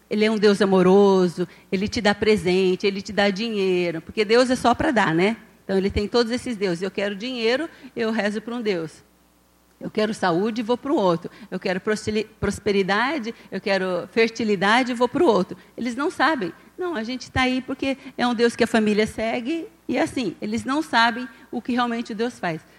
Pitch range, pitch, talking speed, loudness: 195-245 Hz, 220 Hz, 205 wpm, -22 LUFS